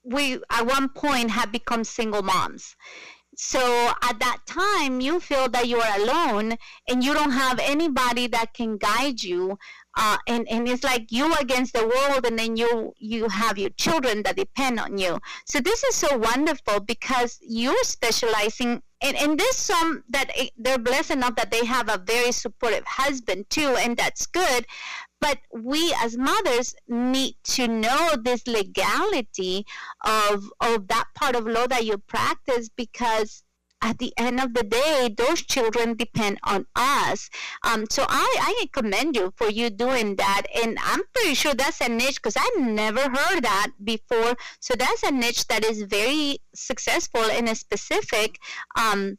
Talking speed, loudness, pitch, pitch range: 170 wpm, -23 LUFS, 240 Hz, 225-270 Hz